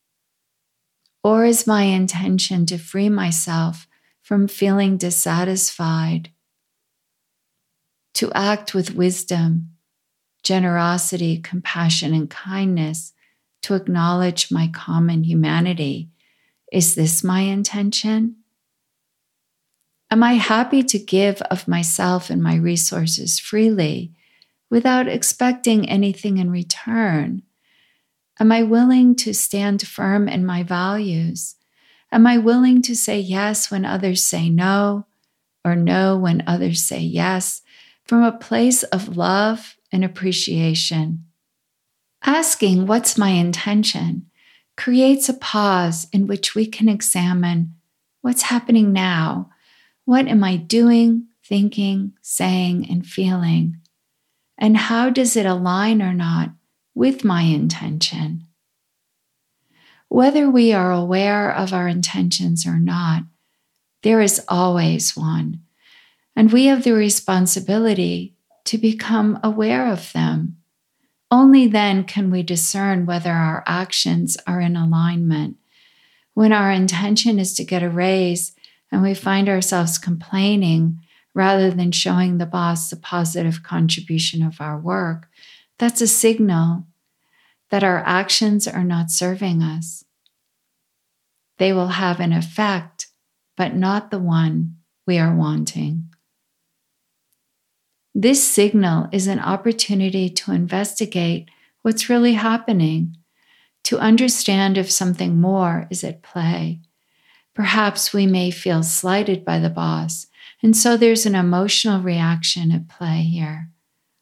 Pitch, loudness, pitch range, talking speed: 185 Hz, -18 LUFS, 165-210 Hz, 115 wpm